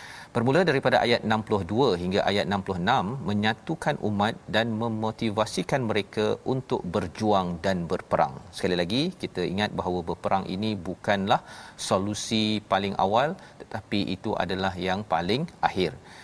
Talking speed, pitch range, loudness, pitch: 120 wpm, 95-110 Hz, -26 LUFS, 105 Hz